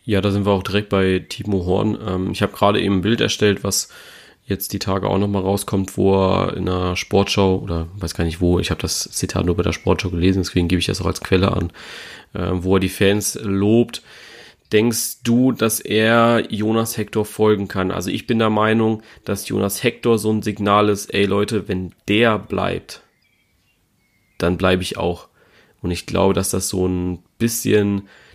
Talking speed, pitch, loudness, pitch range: 200 wpm, 100 Hz, -19 LUFS, 95-105 Hz